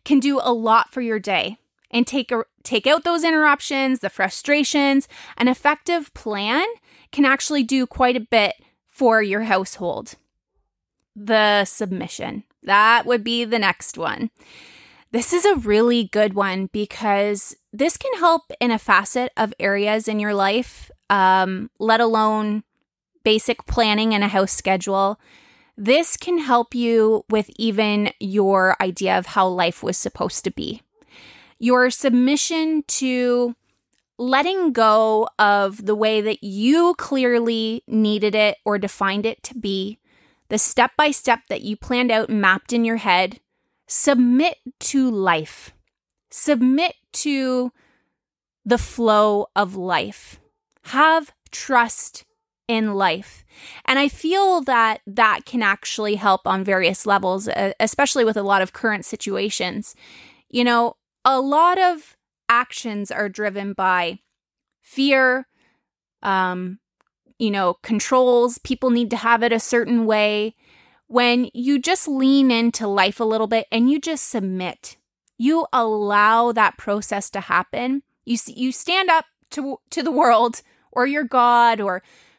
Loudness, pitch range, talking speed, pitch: -19 LUFS, 210-265 Hz, 140 wpm, 235 Hz